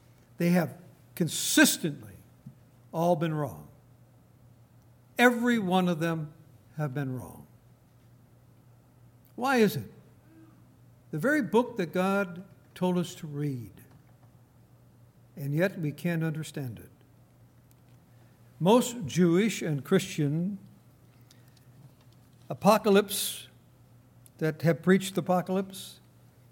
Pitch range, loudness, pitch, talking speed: 125-180 Hz, -28 LUFS, 135 Hz, 95 wpm